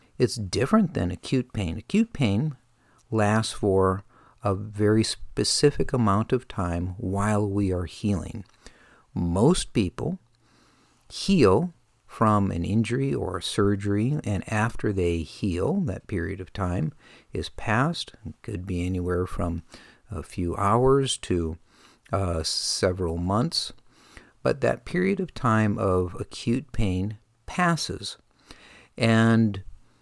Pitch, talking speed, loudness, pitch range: 105 Hz, 120 wpm, -25 LUFS, 90-120 Hz